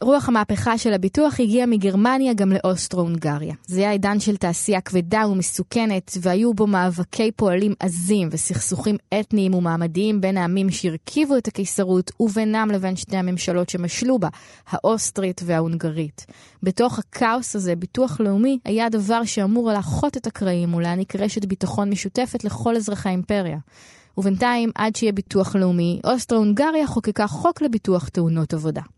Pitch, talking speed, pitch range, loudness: 200 Hz, 135 wpm, 180-225 Hz, -21 LUFS